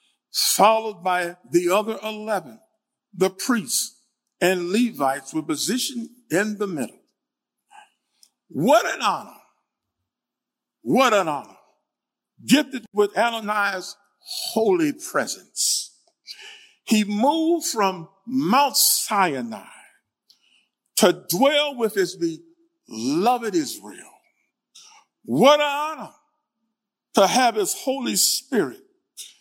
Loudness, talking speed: -21 LUFS, 90 wpm